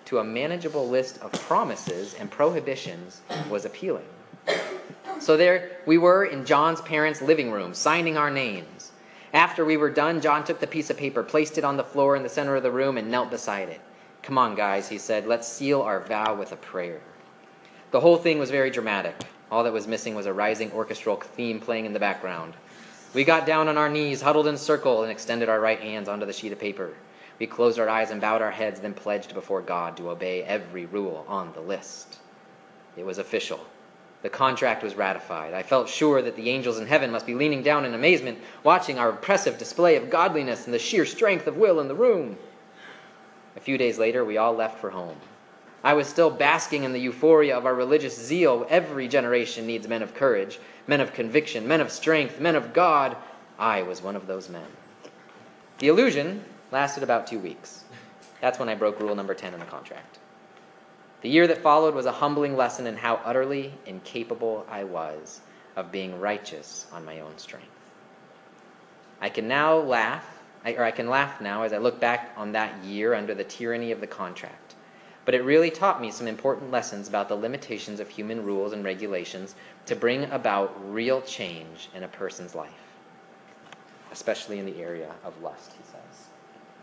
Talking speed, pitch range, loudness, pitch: 200 wpm, 105-145 Hz, -25 LUFS, 120 Hz